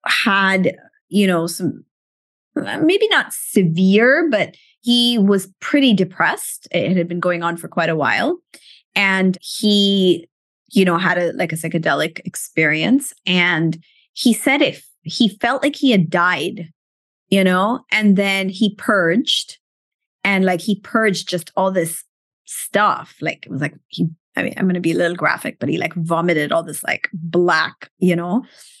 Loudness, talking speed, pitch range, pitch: -17 LUFS, 165 wpm, 170-225 Hz, 190 Hz